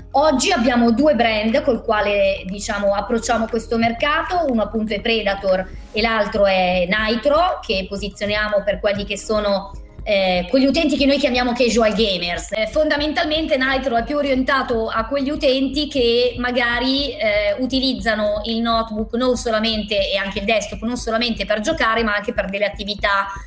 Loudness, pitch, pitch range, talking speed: -18 LUFS, 230 Hz, 210-270 Hz, 155 wpm